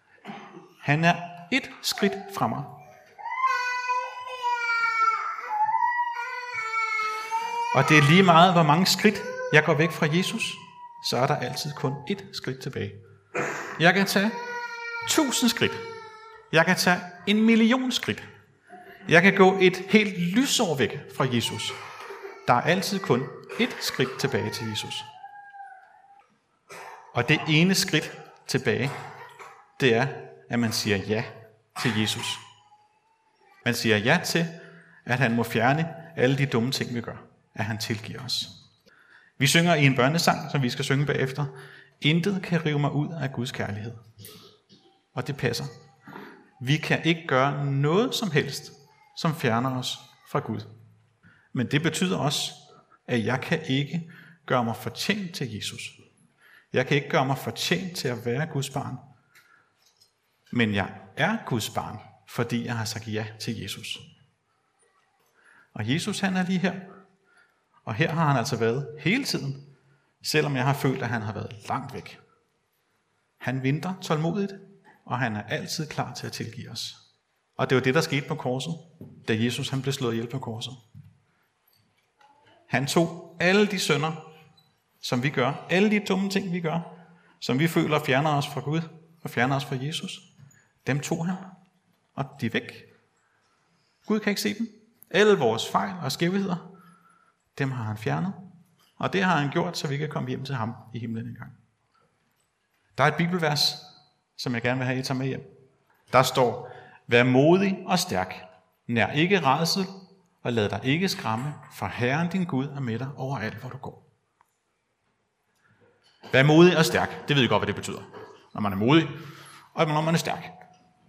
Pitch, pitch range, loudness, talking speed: 155 Hz, 125-190 Hz, -25 LUFS, 165 wpm